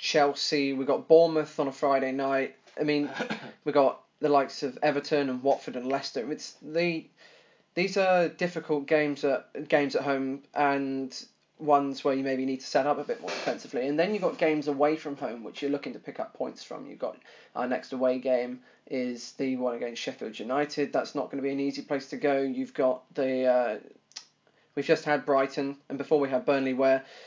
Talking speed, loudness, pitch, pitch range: 210 wpm, -28 LUFS, 140 Hz, 135-150 Hz